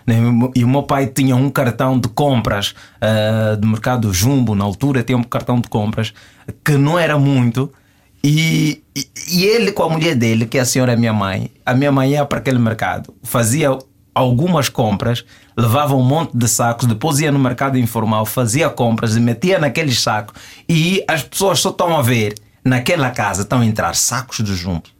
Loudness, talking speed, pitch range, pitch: -16 LUFS, 190 wpm, 115-140 Hz, 125 Hz